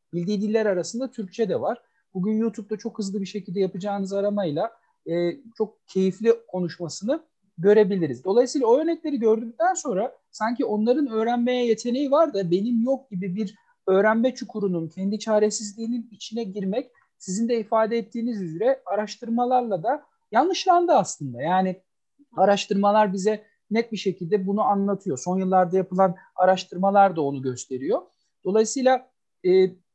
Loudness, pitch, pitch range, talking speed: -24 LUFS, 210 Hz, 190-235 Hz, 130 wpm